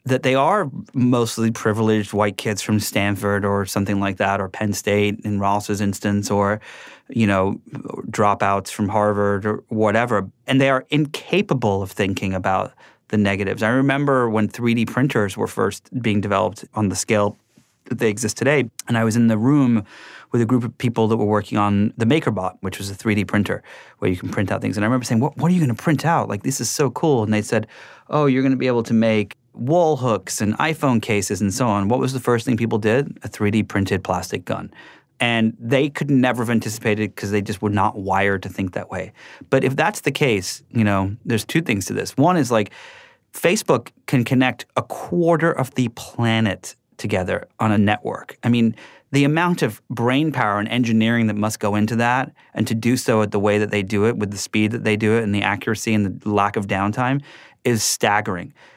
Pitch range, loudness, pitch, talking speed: 105-125 Hz, -20 LUFS, 110 Hz, 215 wpm